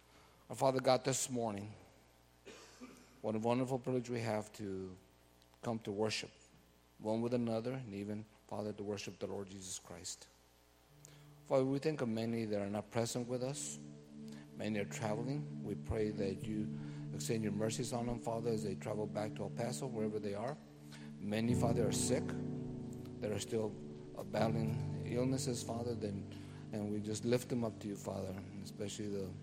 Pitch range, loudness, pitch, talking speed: 75-120 Hz, -40 LUFS, 105 Hz, 170 wpm